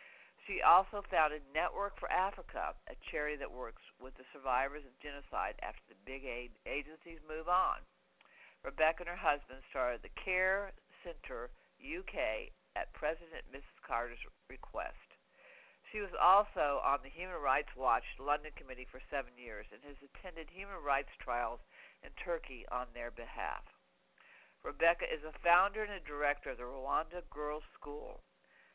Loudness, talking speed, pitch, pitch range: -37 LUFS, 150 wpm, 150 Hz, 135-185 Hz